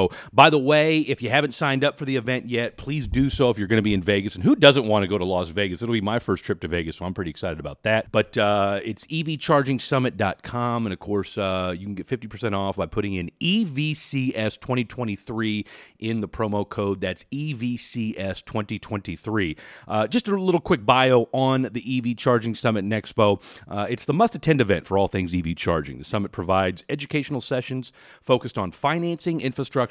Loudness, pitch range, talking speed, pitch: -23 LUFS, 100-135 Hz, 200 wpm, 110 Hz